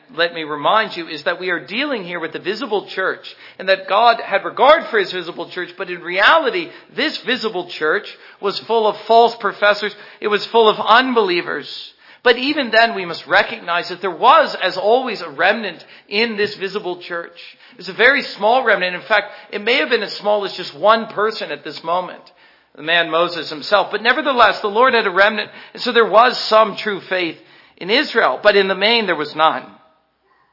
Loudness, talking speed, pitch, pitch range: -16 LUFS, 205 wpm, 205 Hz, 175-230 Hz